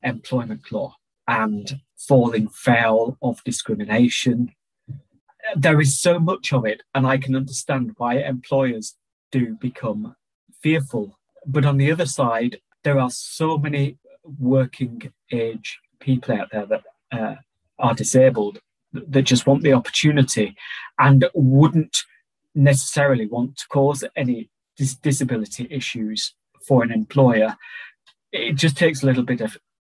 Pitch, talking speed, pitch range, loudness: 130 Hz, 130 wpm, 120-140 Hz, -20 LUFS